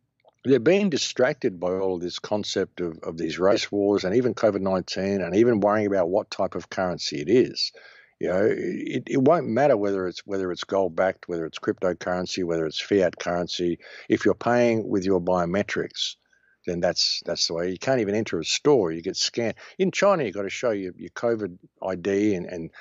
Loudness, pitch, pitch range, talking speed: -24 LUFS, 95 Hz, 90-110 Hz, 205 wpm